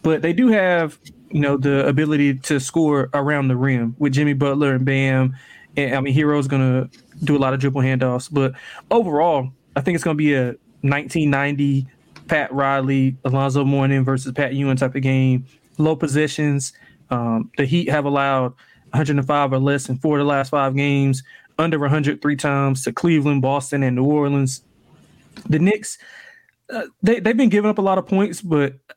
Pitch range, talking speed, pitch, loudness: 135-155 Hz, 190 wpm, 140 Hz, -19 LUFS